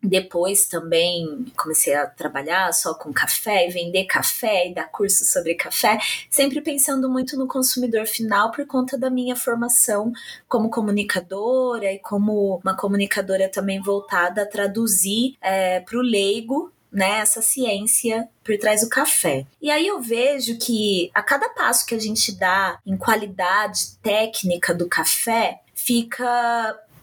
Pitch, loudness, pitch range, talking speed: 215 Hz, -20 LUFS, 195-245 Hz, 145 wpm